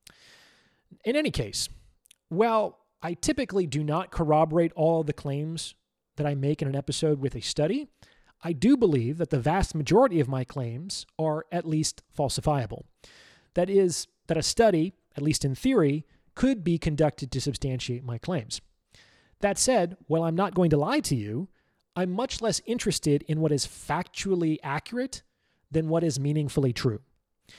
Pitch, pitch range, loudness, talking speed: 155 Hz, 145-180 Hz, -27 LUFS, 165 wpm